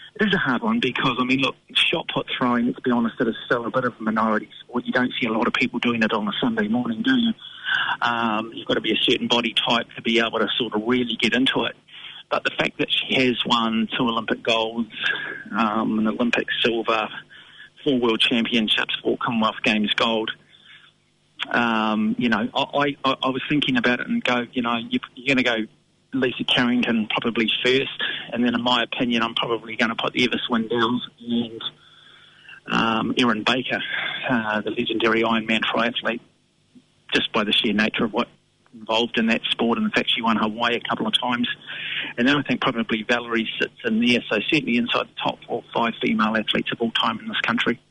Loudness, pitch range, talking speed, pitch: -22 LUFS, 115-125 Hz, 210 wpm, 120 Hz